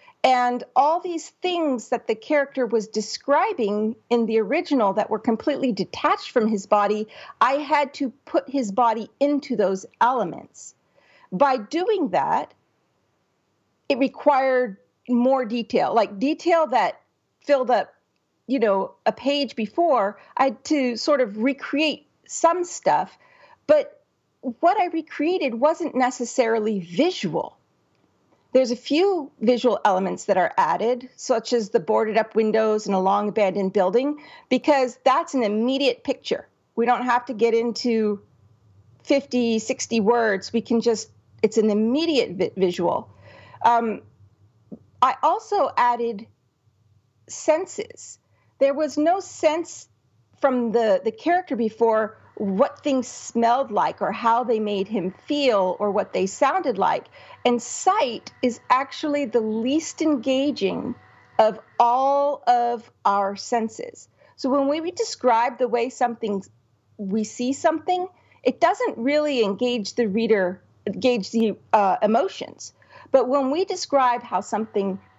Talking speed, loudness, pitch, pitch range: 135 wpm, -22 LUFS, 245 Hz, 220-290 Hz